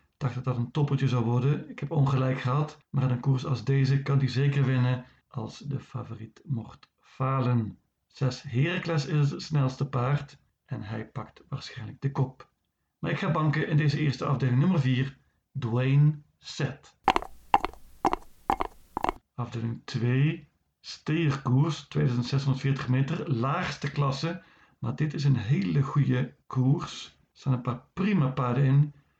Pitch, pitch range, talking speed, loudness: 135 Hz, 125-145 Hz, 150 wpm, -28 LUFS